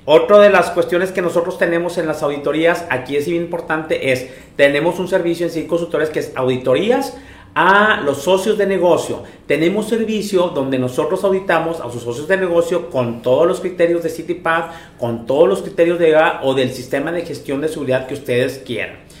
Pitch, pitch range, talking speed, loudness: 165 Hz, 140-175 Hz, 195 wpm, -16 LUFS